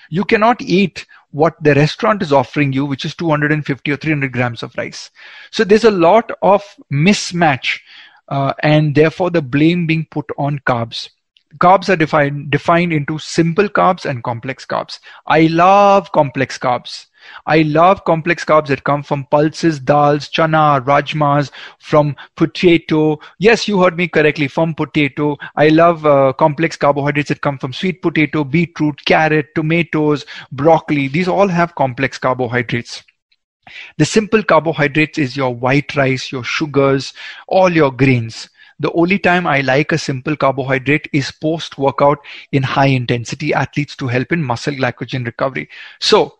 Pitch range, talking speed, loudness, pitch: 140-165 Hz, 155 wpm, -15 LUFS, 150 Hz